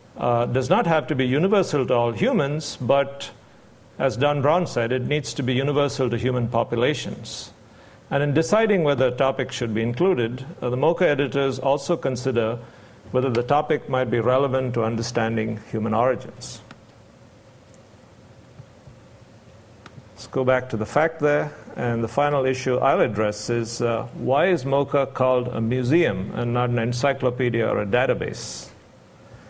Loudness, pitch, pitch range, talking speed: -22 LUFS, 130 Hz, 115-140 Hz, 155 wpm